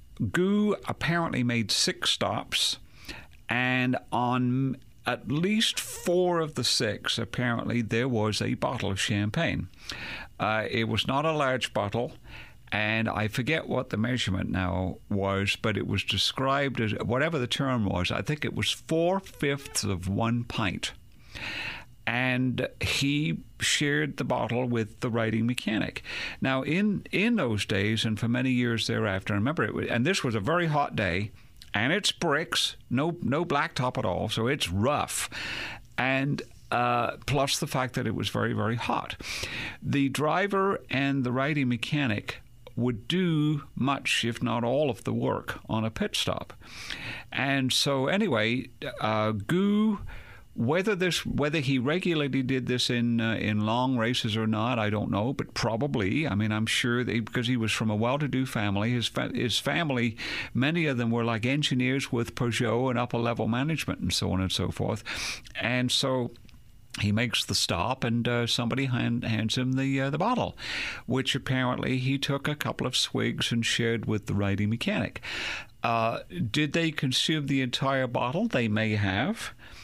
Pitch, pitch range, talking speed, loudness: 120 Hz, 110-135 Hz, 165 wpm, -28 LUFS